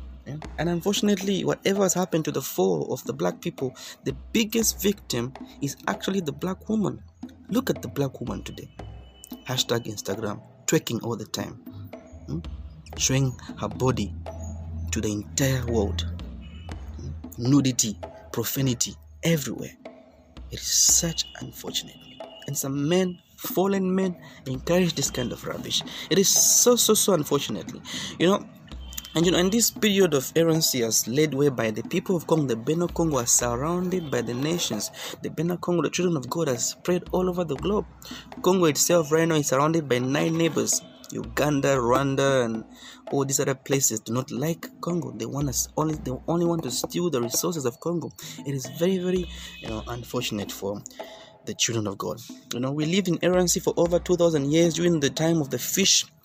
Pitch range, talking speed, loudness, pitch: 120-175 Hz, 175 wpm, -24 LUFS, 145 Hz